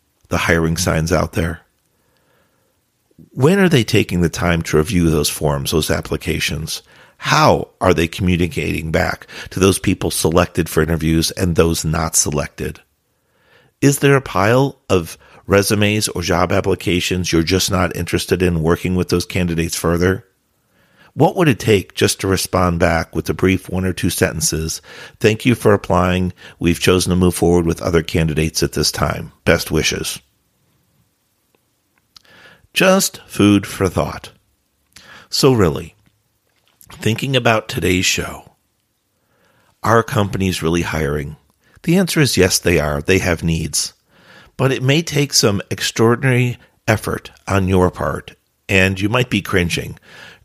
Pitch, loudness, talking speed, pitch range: 90 Hz, -16 LUFS, 145 wpm, 85-105 Hz